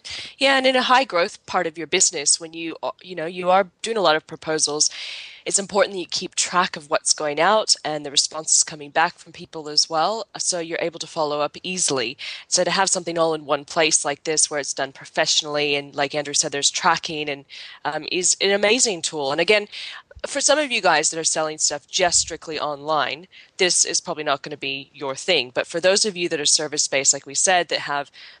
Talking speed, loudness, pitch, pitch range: 230 wpm, -20 LUFS, 160 Hz, 150-180 Hz